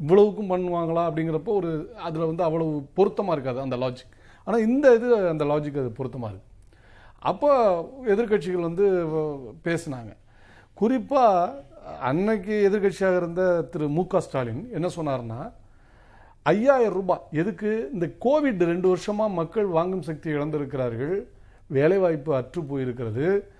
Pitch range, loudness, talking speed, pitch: 140-200 Hz, -24 LUFS, 120 wpm, 170 Hz